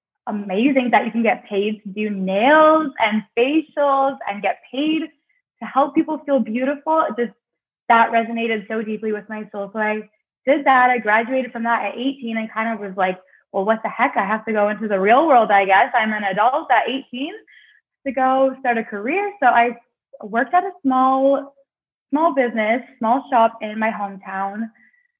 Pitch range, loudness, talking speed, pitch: 215-275 Hz, -19 LUFS, 190 wpm, 235 Hz